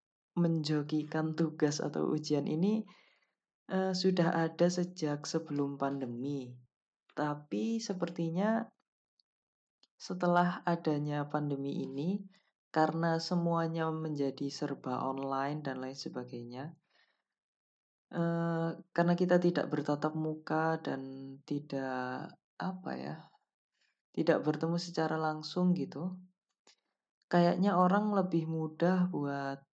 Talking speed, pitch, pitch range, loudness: 90 wpm, 160 Hz, 140-175 Hz, -34 LUFS